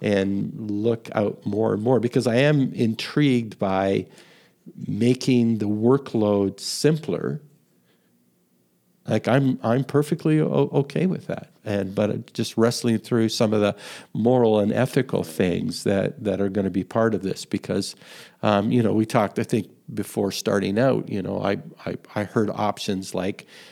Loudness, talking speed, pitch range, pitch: -23 LUFS, 160 wpm, 100-130 Hz, 115 Hz